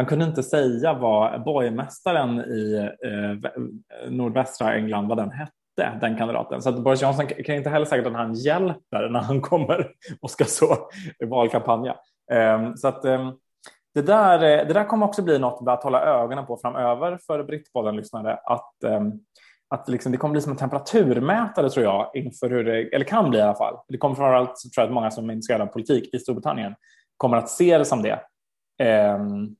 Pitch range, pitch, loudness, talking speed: 115-150 Hz, 130 Hz, -23 LUFS, 200 wpm